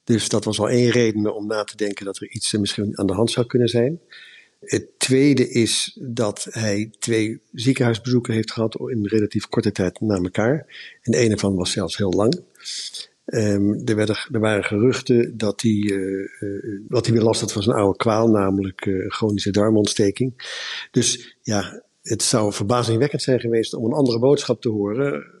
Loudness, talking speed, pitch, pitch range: -21 LUFS, 185 wpm, 110 Hz, 105-120 Hz